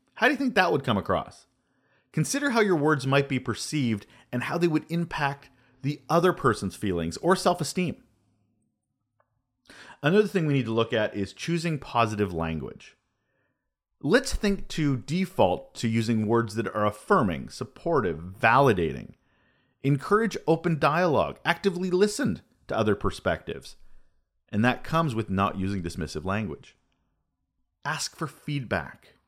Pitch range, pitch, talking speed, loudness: 105-170 Hz, 130 Hz, 140 wpm, -26 LUFS